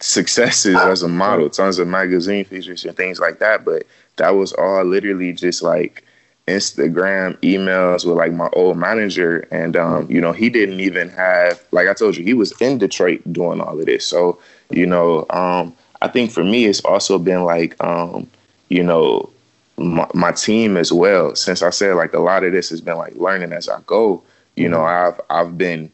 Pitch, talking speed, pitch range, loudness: 90 Hz, 200 wpm, 85-95 Hz, -16 LUFS